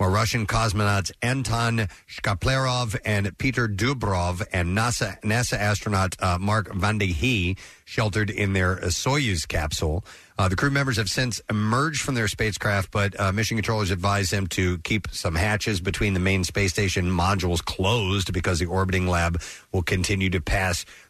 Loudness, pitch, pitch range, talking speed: -24 LUFS, 100 Hz, 95-110 Hz, 160 wpm